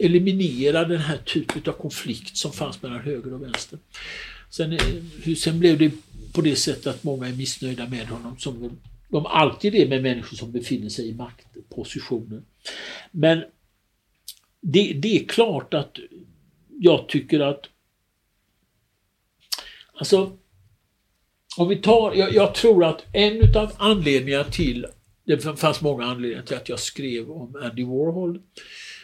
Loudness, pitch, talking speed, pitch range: -22 LUFS, 135 Hz, 145 wpm, 115-165 Hz